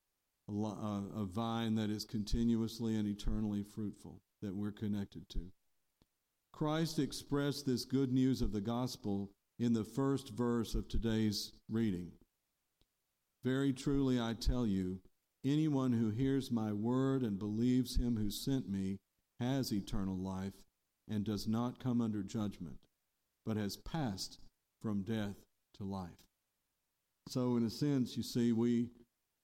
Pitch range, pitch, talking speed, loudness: 100-125 Hz, 110 Hz, 135 wpm, -38 LUFS